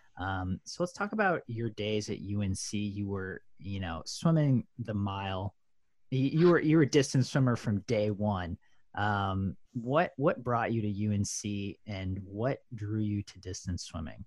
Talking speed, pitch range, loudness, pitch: 170 wpm, 95-130 Hz, -32 LUFS, 105 Hz